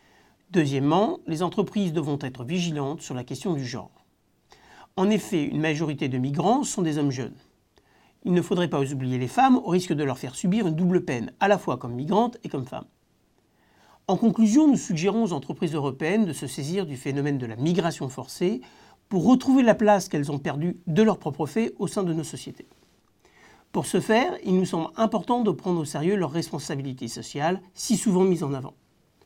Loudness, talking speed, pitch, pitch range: -25 LUFS, 195 wpm, 170 Hz, 145-200 Hz